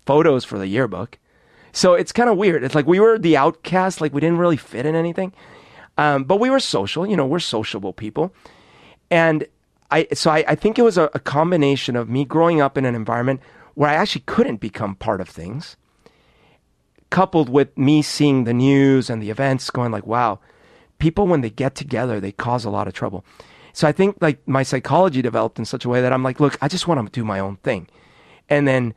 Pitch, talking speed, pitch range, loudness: 140 Hz, 220 wpm, 120-165 Hz, -19 LUFS